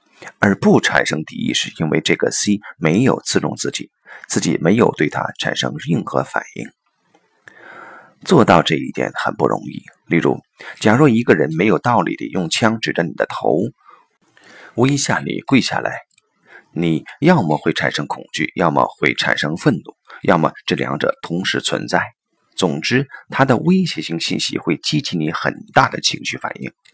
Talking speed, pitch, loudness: 240 characters per minute, 85 Hz, -17 LUFS